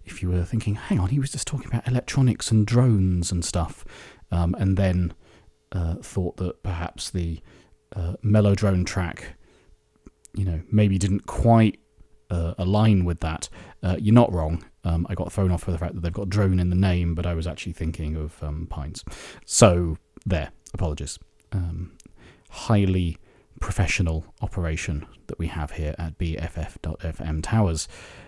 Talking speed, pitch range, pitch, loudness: 165 wpm, 85-100 Hz, 90 Hz, -24 LUFS